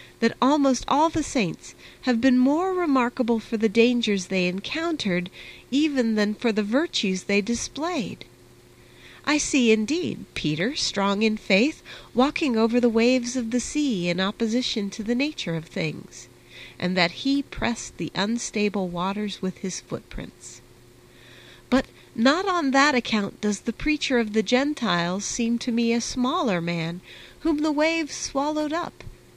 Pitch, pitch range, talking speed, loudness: 230 Hz, 185-270 Hz, 150 wpm, -24 LUFS